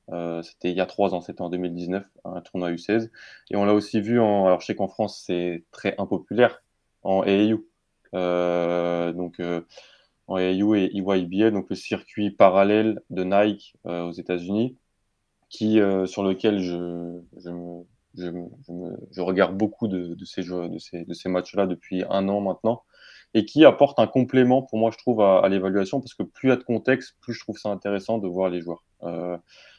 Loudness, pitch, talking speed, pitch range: -24 LUFS, 95 Hz, 200 wpm, 90-110 Hz